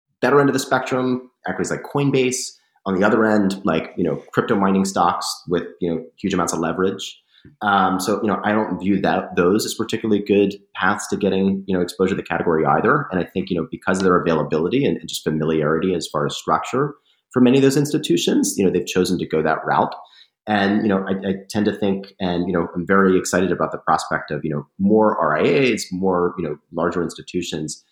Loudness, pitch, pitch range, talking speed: -20 LUFS, 95 Hz, 90-110 Hz, 215 wpm